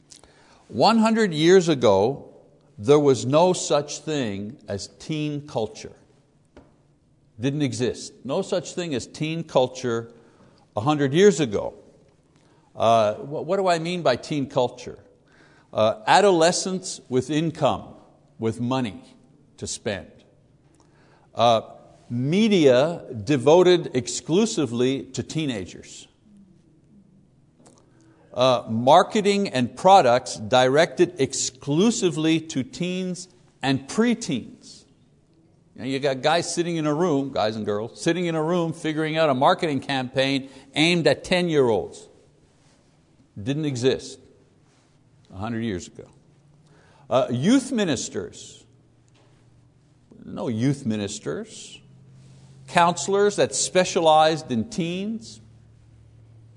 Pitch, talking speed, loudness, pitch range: 145 Hz, 100 wpm, -22 LUFS, 125-170 Hz